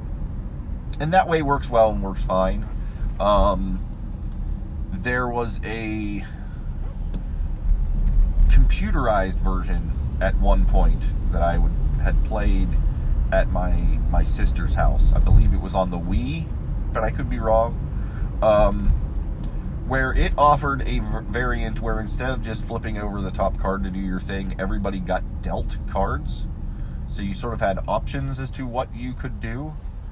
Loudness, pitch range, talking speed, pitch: -24 LUFS, 70-110 Hz, 145 wpm, 95 Hz